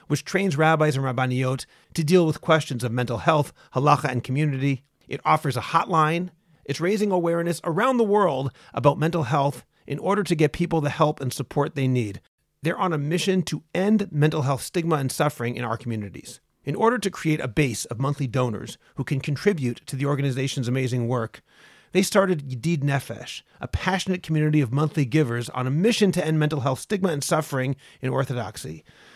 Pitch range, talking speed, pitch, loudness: 130-170 Hz, 190 wpm, 150 Hz, -24 LUFS